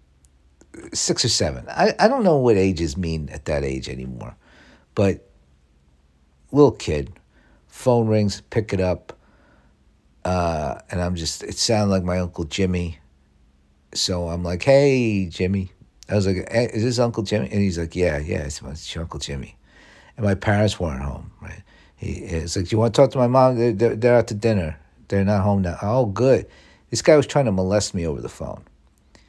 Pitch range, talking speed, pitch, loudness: 70-105 Hz, 185 wpm, 90 Hz, -21 LUFS